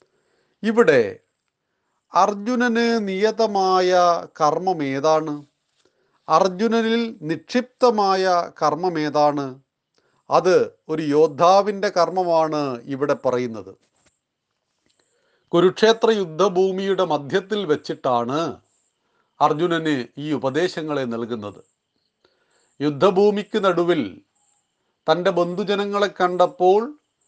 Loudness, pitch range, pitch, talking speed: -20 LUFS, 150-205 Hz, 180 Hz, 60 wpm